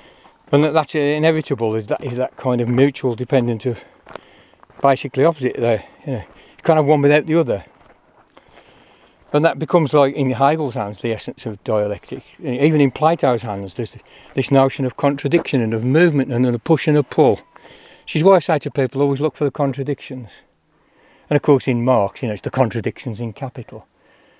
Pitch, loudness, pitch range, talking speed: 135 Hz, -18 LUFS, 120-150 Hz, 190 wpm